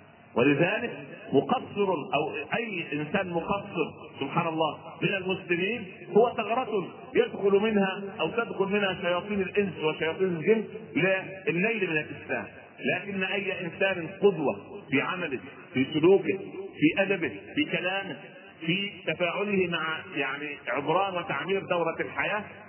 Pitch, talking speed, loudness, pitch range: 190 Hz, 115 wpm, -28 LUFS, 165-200 Hz